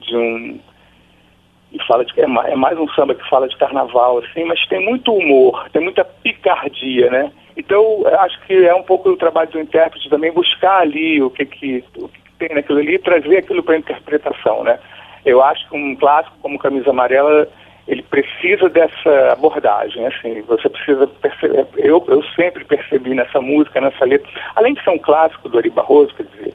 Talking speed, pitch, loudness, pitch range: 190 wpm, 160 Hz, -14 LUFS, 140-215 Hz